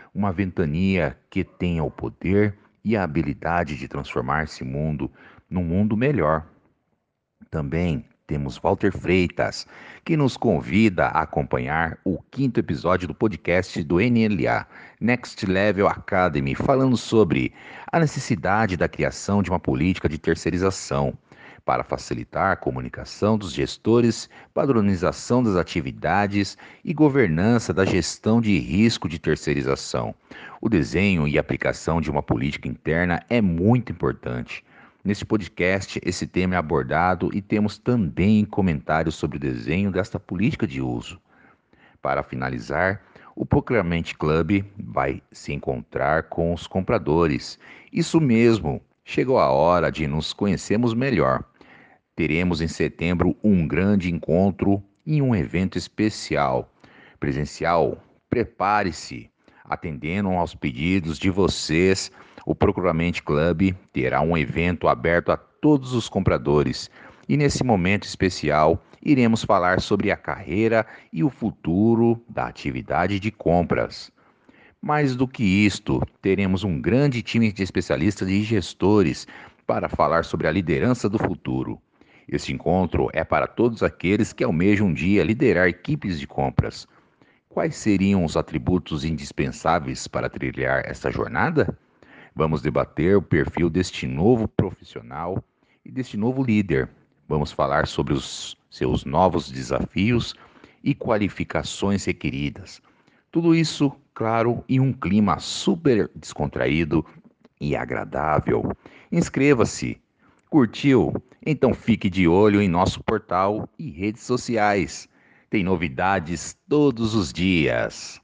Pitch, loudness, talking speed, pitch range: 95 Hz, -23 LUFS, 125 wpm, 80-110 Hz